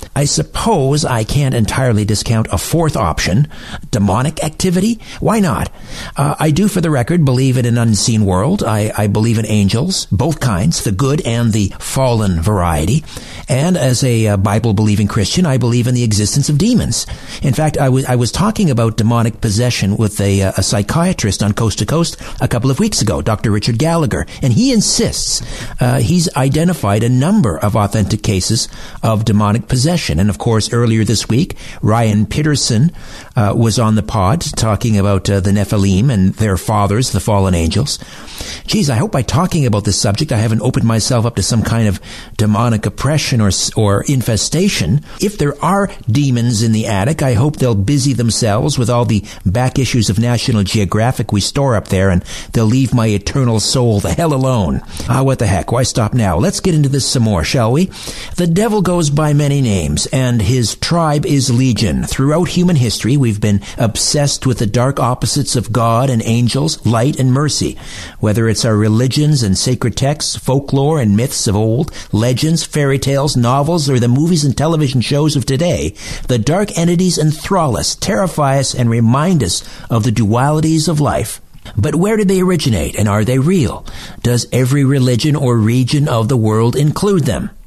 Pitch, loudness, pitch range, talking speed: 120 Hz, -14 LUFS, 105-145 Hz, 185 wpm